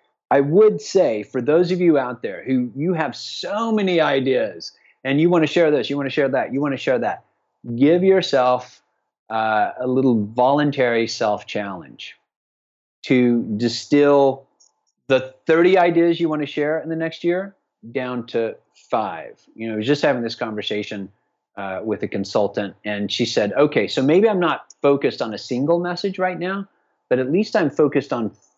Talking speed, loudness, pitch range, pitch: 185 wpm, -20 LUFS, 120-170 Hz, 140 Hz